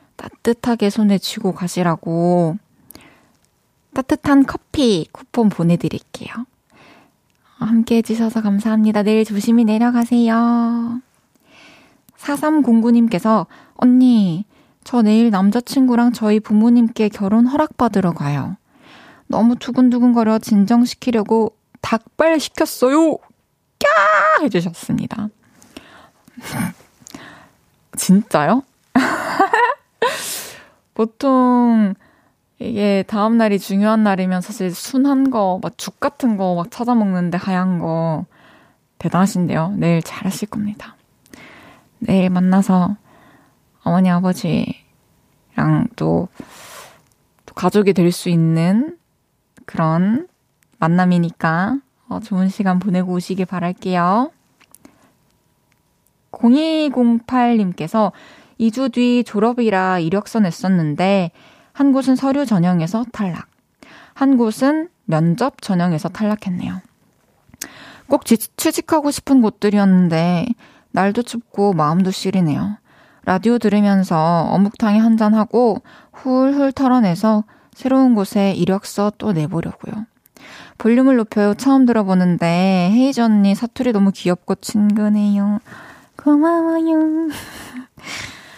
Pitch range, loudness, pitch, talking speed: 185-245 Hz, -17 LUFS, 215 Hz, 225 characters per minute